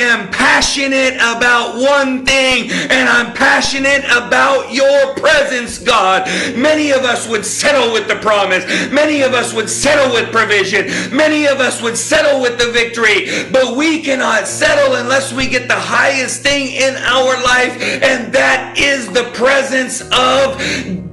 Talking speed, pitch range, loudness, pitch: 155 wpm, 235-275 Hz, -12 LUFS, 260 Hz